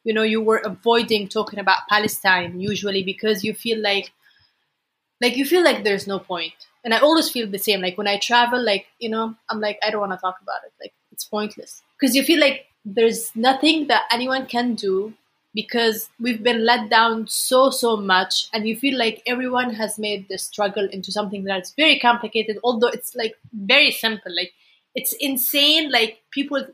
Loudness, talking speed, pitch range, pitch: -20 LUFS, 195 wpm, 205-245 Hz, 225 Hz